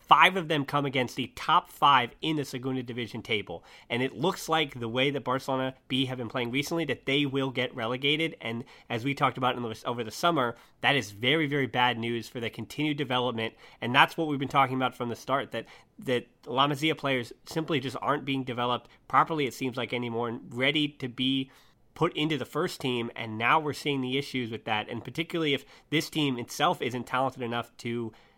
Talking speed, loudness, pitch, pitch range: 220 wpm, -28 LUFS, 130 Hz, 120-145 Hz